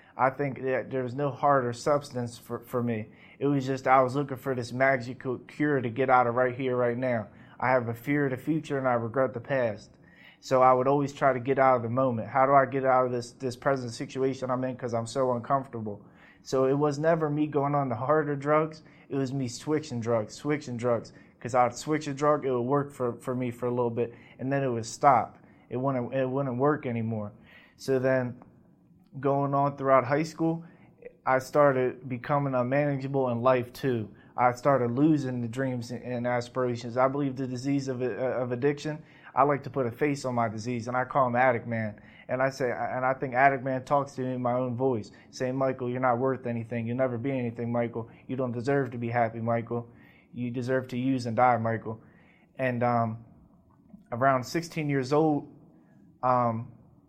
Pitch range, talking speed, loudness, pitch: 120-140 Hz, 210 wpm, -28 LUFS, 130 Hz